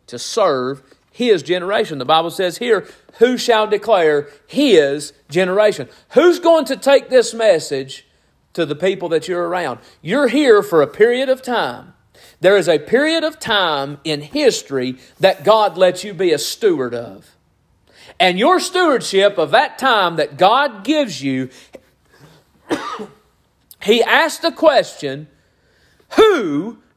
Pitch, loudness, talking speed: 200 Hz, -16 LUFS, 140 wpm